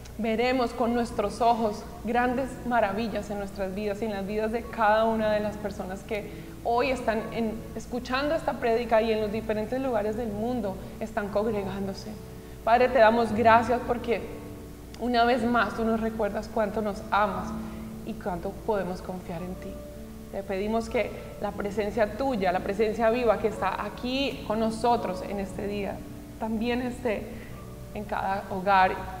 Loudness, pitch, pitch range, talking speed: -27 LUFS, 220 Hz, 200-235 Hz, 160 wpm